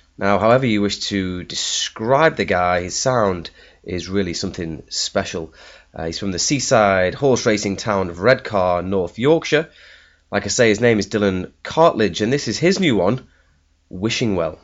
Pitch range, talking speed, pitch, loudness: 90-125 Hz, 170 wpm, 100 Hz, -18 LUFS